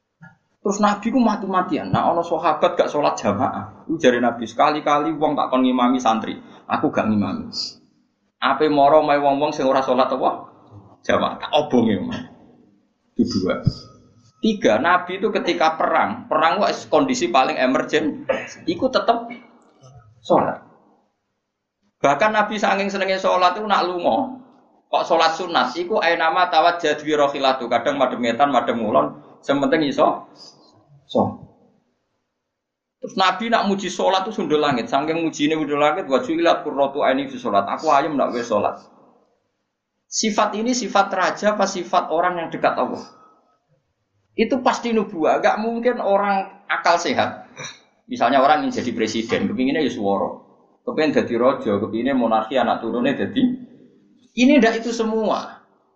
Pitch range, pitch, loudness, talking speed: 140-225 Hz, 180 Hz, -20 LUFS, 140 wpm